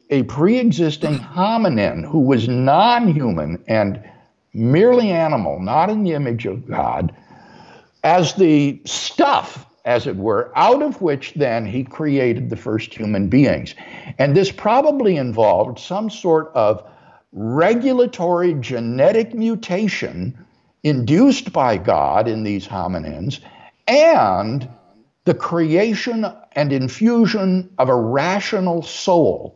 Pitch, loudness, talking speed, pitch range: 155 Hz, -17 LUFS, 120 wpm, 125-200 Hz